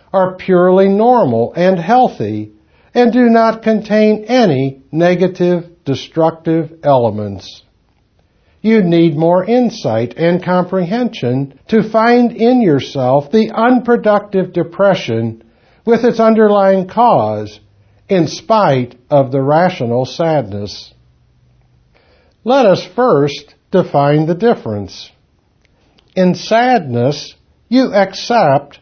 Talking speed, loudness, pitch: 95 wpm, -13 LUFS, 175 Hz